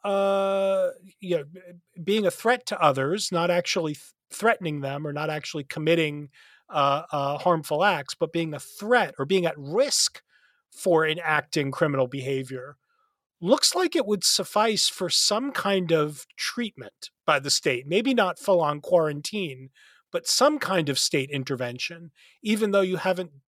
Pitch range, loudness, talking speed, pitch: 150-205 Hz, -24 LUFS, 155 wpm, 175 Hz